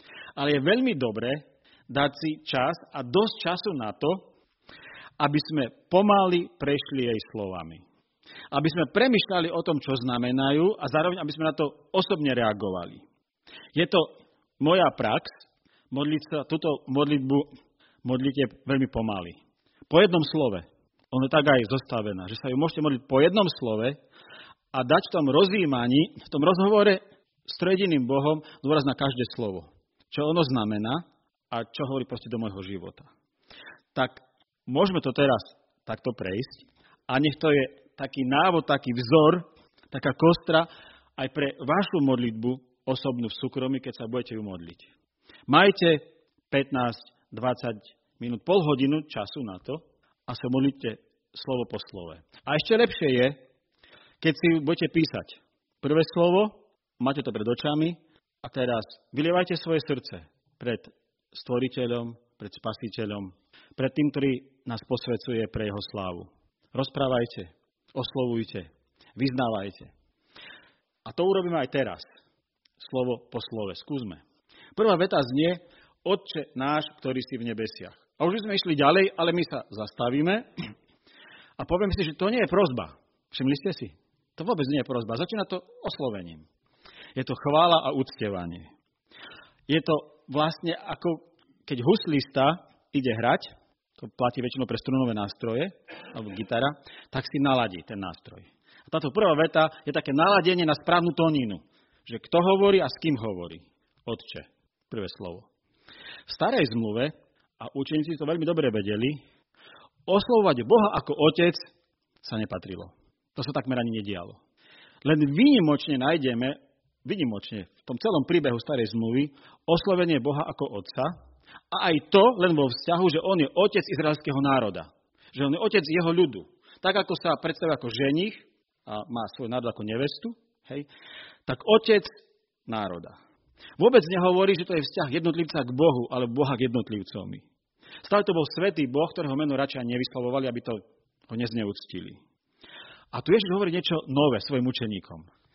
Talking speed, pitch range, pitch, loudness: 145 wpm, 120-165 Hz, 140 Hz, -26 LUFS